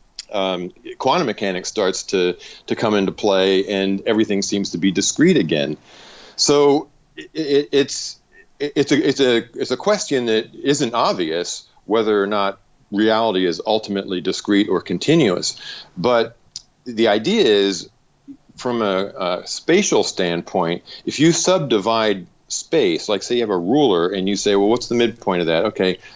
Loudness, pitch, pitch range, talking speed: -19 LUFS, 110 Hz, 95-125 Hz, 160 wpm